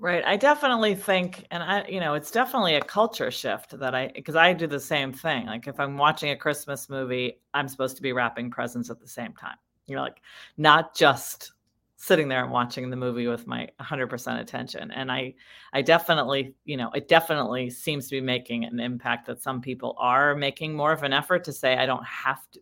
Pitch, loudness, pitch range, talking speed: 140 Hz, -25 LUFS, 125-165 Hz, 220 wpm